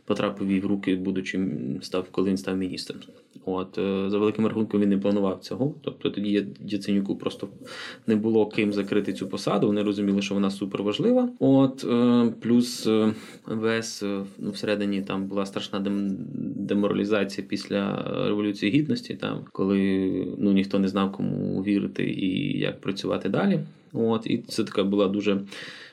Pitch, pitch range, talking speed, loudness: 100 Hz, 95-110 Hz, 150 wpm, -26 LUFS